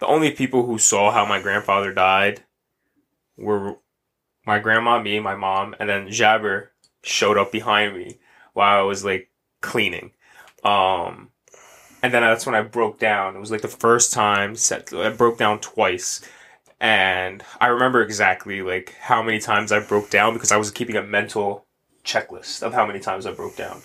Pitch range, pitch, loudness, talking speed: 100-115 Hz, 105 Hz, -20 LUFS, 180 wpm